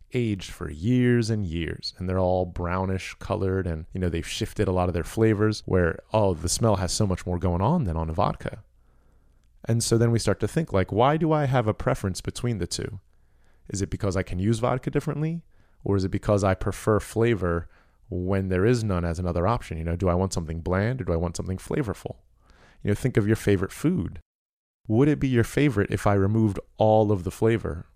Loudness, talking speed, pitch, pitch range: -25 LUFS, 225 wpm, 100 Hz, 90-115 Hz